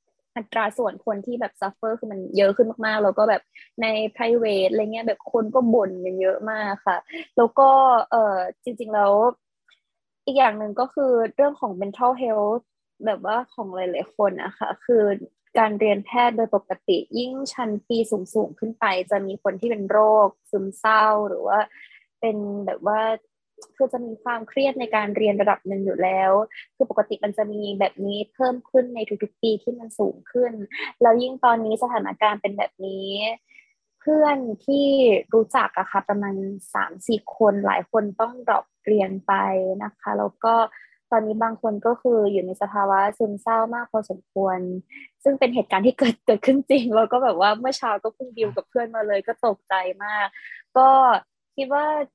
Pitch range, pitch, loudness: 200-245 Hz, 220 Hz, -22 LUFS